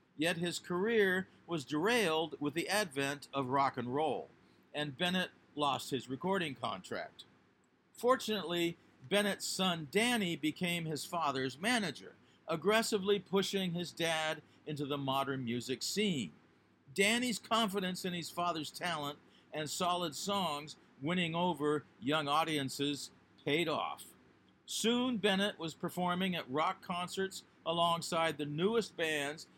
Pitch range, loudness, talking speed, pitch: 145-195 Hz, -35 LUFS, 125 wpm, 170 Hz